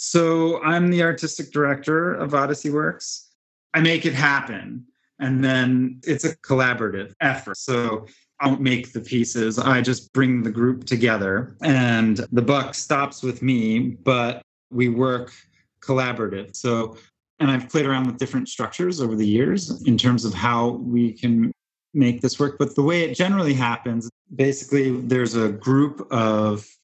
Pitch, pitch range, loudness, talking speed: 130 Hz, 120-140 Hz, -21 LUFS, 160 wpm